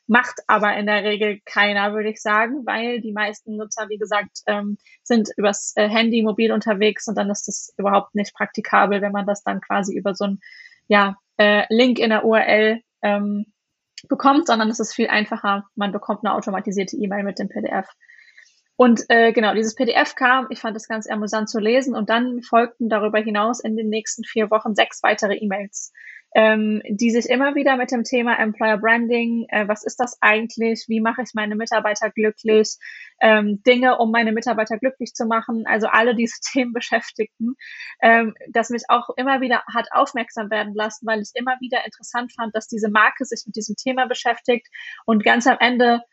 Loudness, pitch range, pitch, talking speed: -19 LUFS, 210-240 Hz, 225 Hz, 190 wpm